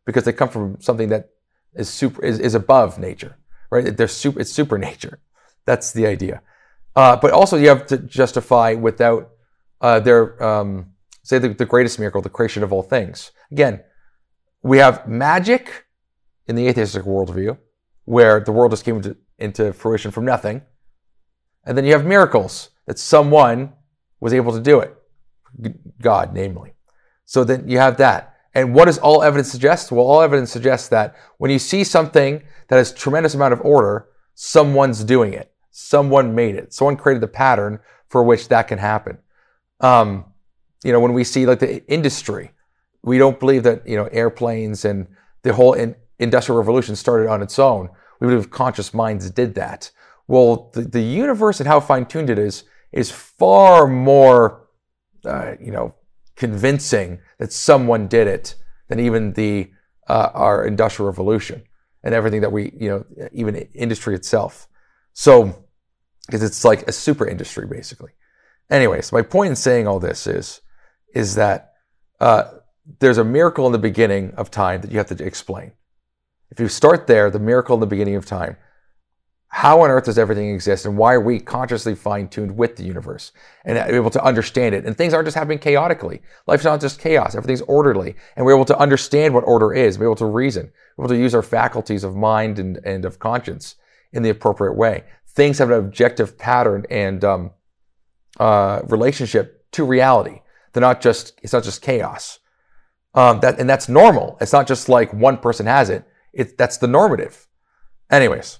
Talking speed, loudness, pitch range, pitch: 180 wpm, -16 LUFS, 105-130 Hz, 115 Hz